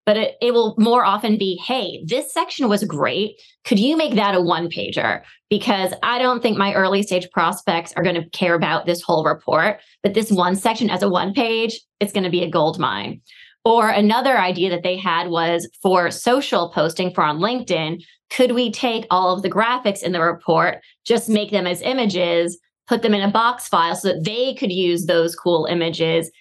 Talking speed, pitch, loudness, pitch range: 210 wpm, 195 Hz, -19 LUFS, 175-230 Hz